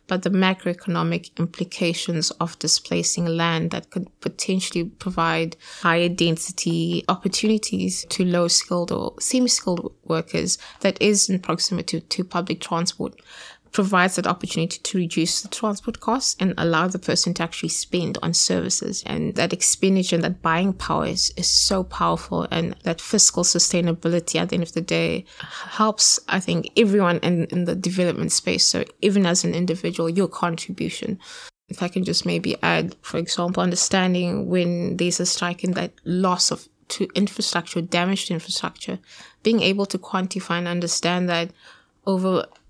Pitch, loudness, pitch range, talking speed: 175 Hz, -21 LUFS, 170-190 Hz, 155 wpm